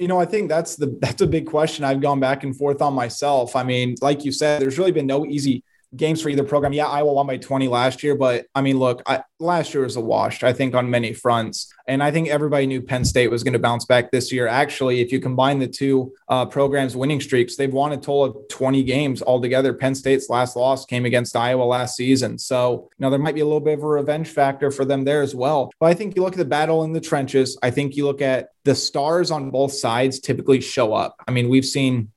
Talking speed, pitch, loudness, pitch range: 260 wpm, 135 Hz, -20 LUFS, 125-145 Hz